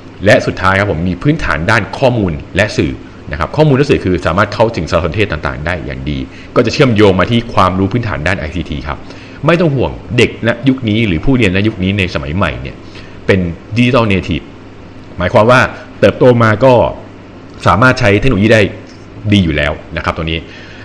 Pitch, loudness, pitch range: 95 Hz, -12 LUFS, 85-110 Hz